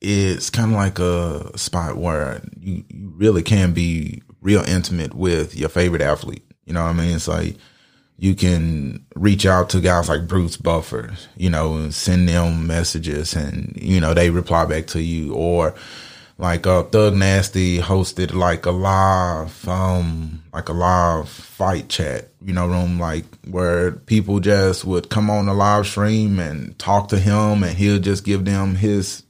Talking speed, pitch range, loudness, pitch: 175 wpm, 85-100 Hz, -19 LUFS, 90 Hz